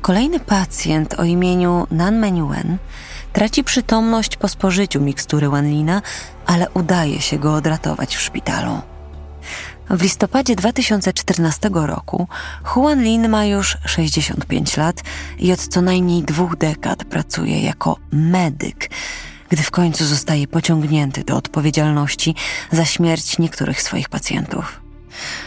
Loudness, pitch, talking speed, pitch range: -18 LUFS, 170 Hz, 120 wpm, 150-190 Hz